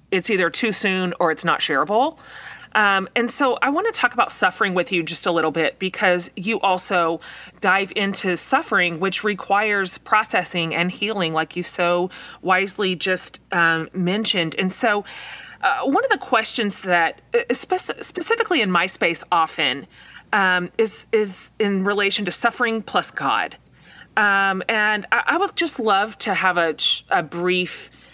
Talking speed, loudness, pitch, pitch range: 160 wpm, -20 LUFS, 195 Hz, 180-215 Hz